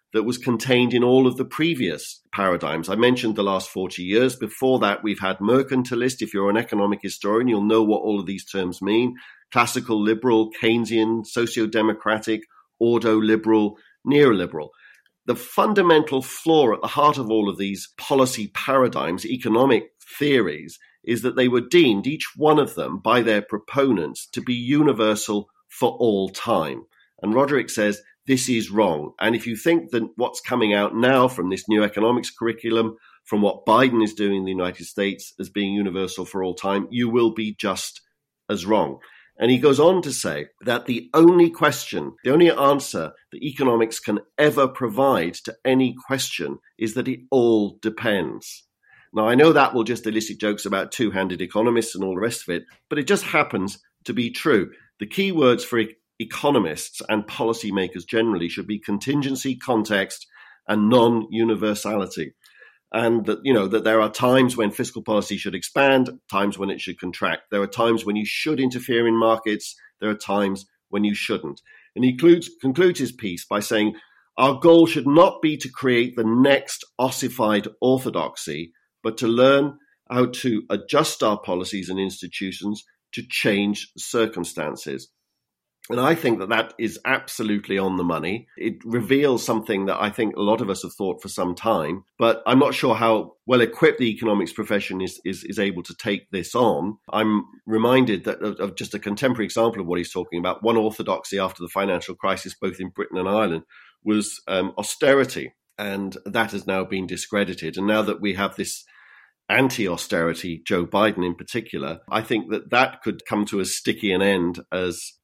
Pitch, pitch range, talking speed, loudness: 110 Hz, 100-125 Hz, 180 wpm, -21 LUFS